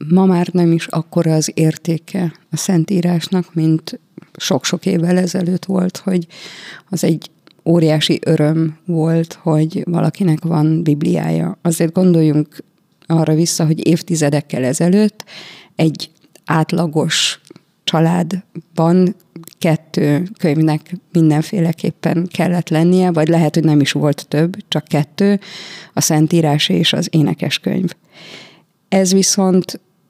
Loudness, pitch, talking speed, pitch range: -16 LUFS, 170 Hz, 110 wpm, 160-180 Hz